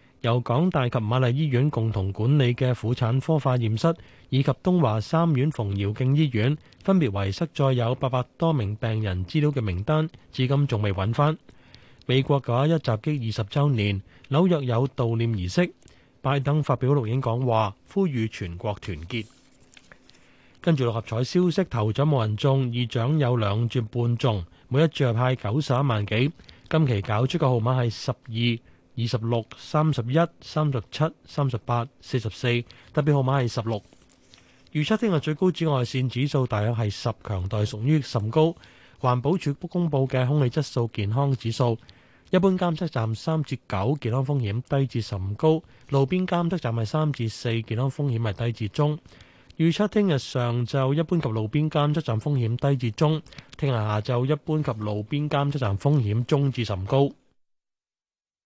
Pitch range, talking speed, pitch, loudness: 115-150 Hz, 255 characters per minute, 130 Hz, -25 LUFS